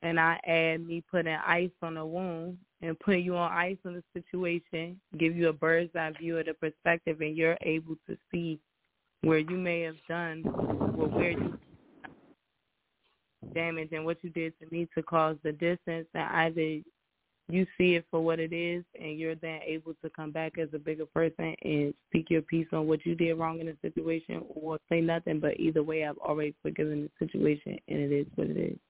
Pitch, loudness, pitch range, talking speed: 165 Hz, -31 LUFS, 160-170 Hz, 205 wpm